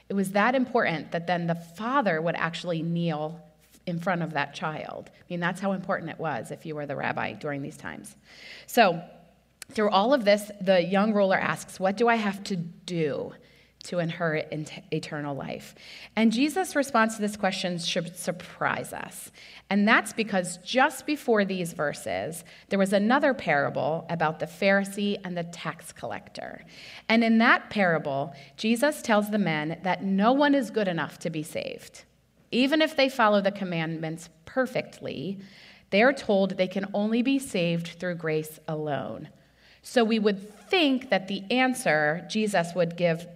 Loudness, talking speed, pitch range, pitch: -26 LUFS, 170 wpm, 165-215 Hz, 190 Hz